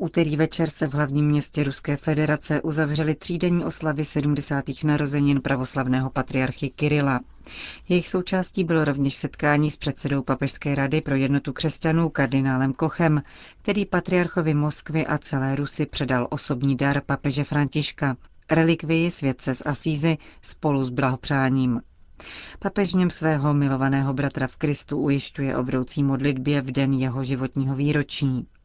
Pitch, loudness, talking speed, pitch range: 145 Hz, -24 LUFS, 130 wpm, 135-155 Hz